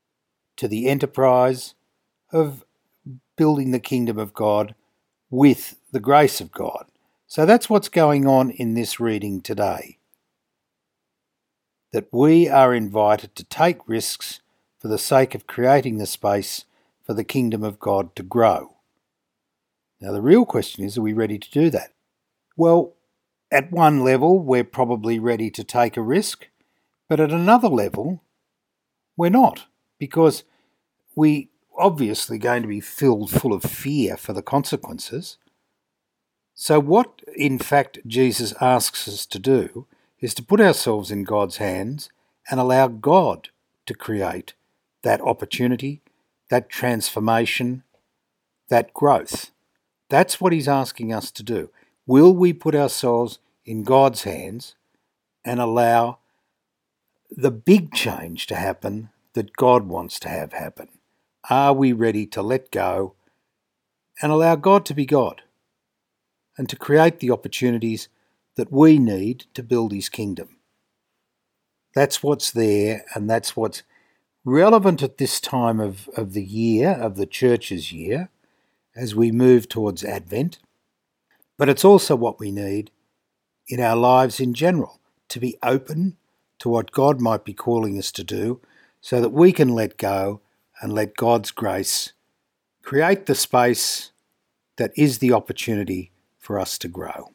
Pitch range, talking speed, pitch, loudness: 110-145 Hz, 140 wpm, 125 Hz, -20 LUFS